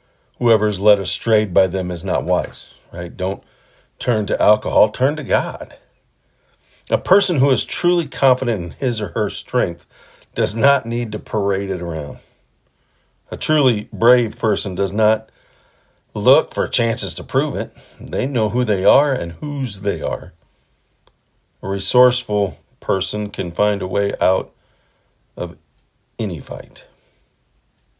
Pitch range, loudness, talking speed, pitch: 95-125 Hz, -18 LUFS, 145 wpm, 105 Hz